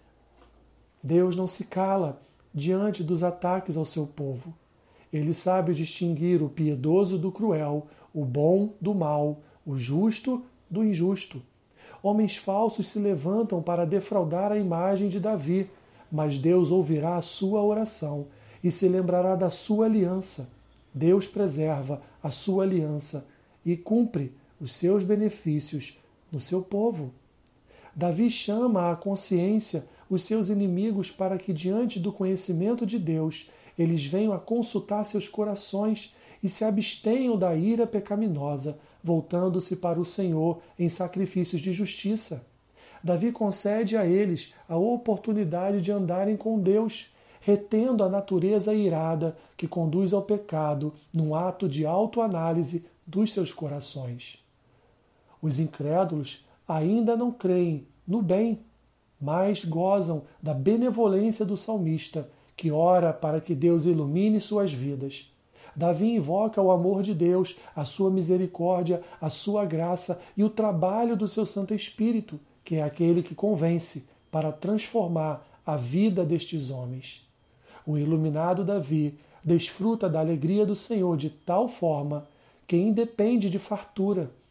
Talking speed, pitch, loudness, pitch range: 130 wpm, 180 Hz, -27 LUFS, 155-205 Hz